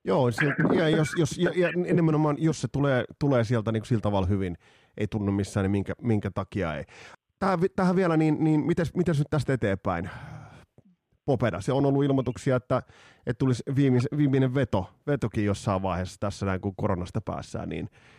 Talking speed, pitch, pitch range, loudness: 185 wpm, 125 Hz, 100-150 Hz, -26 LUFS